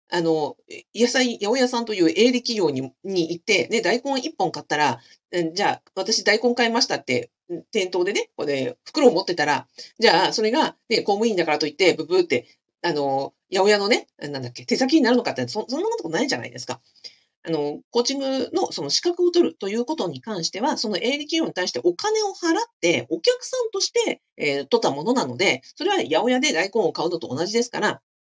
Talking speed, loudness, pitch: 400 characters per minute, -22 LUFS, 235 Hz